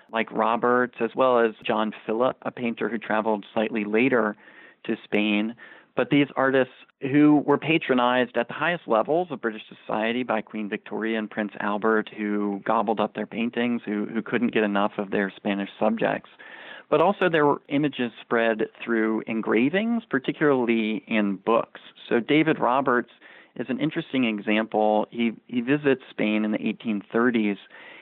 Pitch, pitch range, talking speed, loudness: 115 Hz, 110-130 Hz, 155 wpm, -24 LUFS